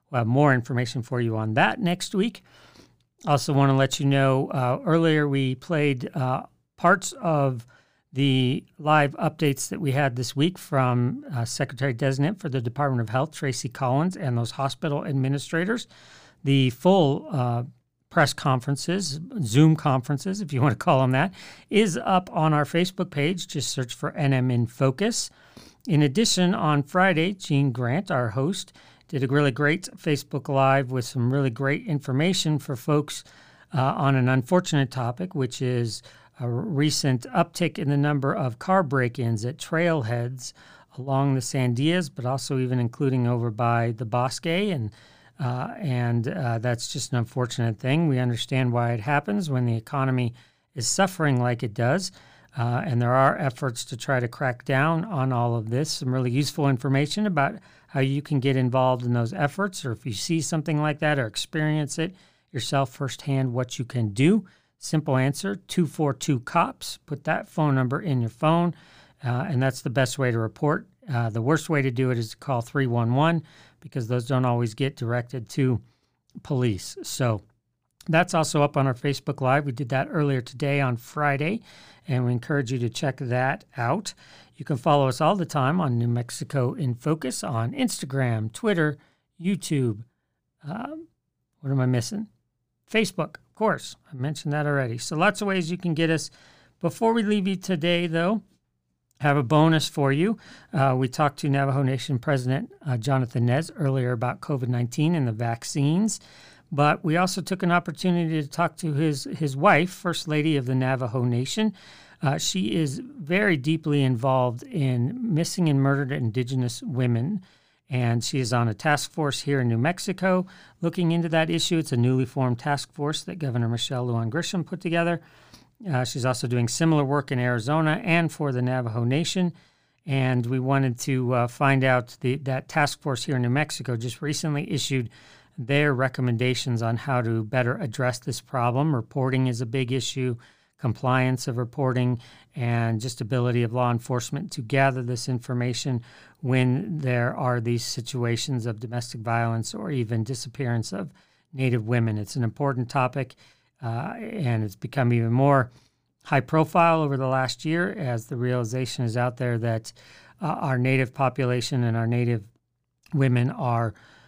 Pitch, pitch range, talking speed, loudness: 135 Hz, 125-155 Hz, 175 wpm, -25 LUFS